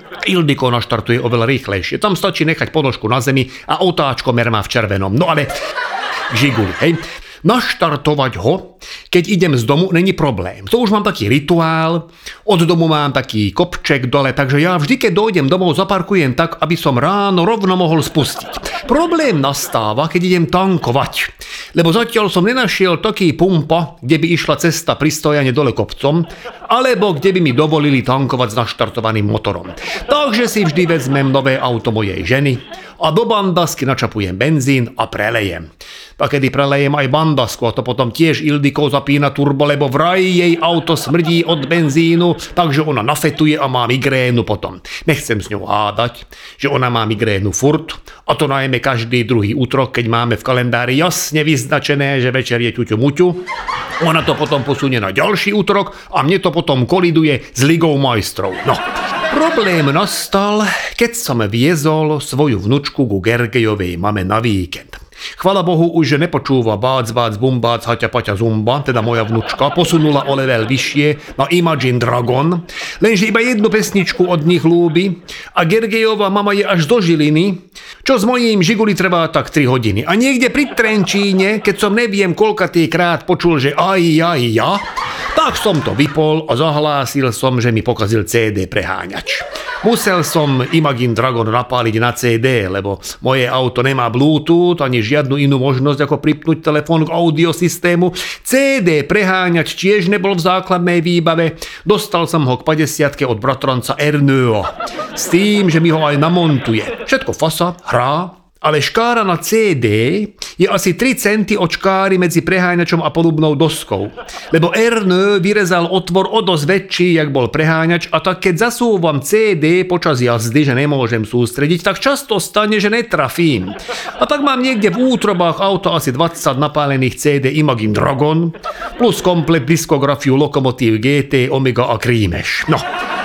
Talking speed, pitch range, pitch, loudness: 160 wpm, 130-180 Hz, 155 Hz, -14 LUFS